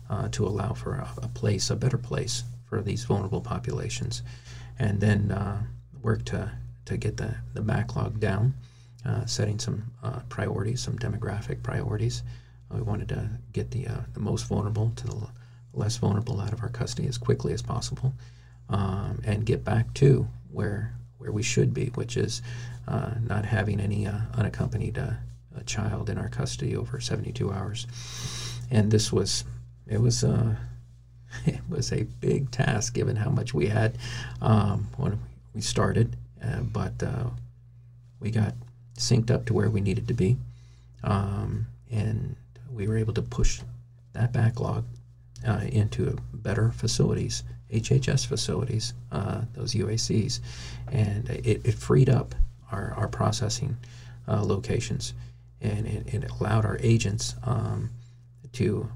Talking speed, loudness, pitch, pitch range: 155 wpm, -28 LUFS, 120 Hz, 110-125 Hz